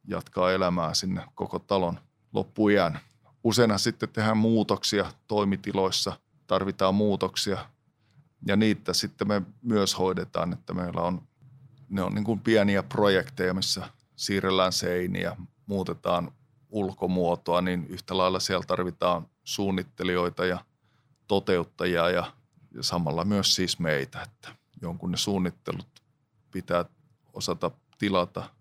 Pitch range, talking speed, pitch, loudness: 90-110 Hz, 115 wpm, 100 Hz, -27 LUFS